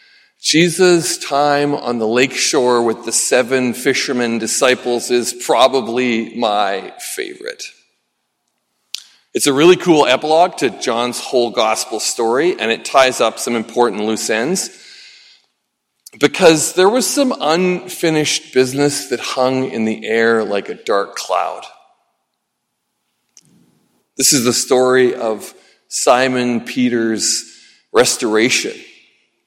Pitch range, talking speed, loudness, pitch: 120-155 Hz, 115 wpm, -15 LUFS, 130 Hz